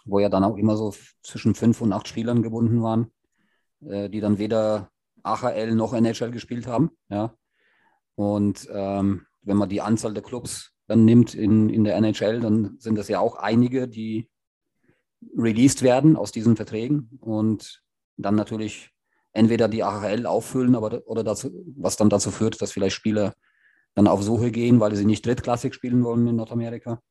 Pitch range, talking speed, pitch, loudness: 105-120 Hz, 175 wpm, 110 Hz, -23 LUFS